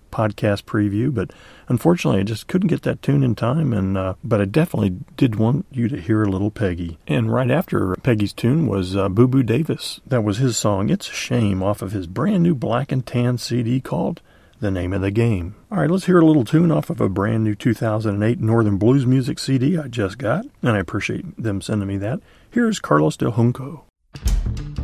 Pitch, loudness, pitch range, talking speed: 115 Hz, -20 LUFS, 100-140 Hz, 215 wpm